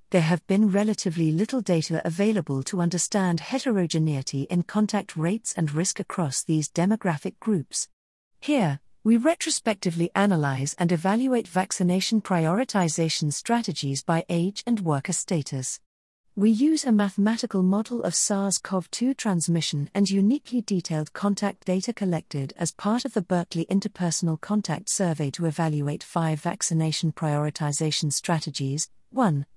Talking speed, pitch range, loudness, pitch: 130 wpm, 160-205 Hz, -25 LUFS, 180 Hz